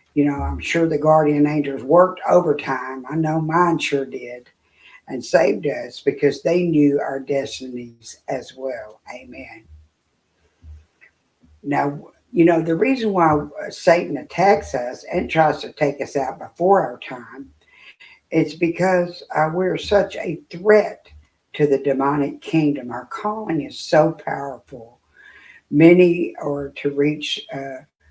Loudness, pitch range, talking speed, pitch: -19 LUFS, 130-165 Hz, 135 wpm, 145 Hz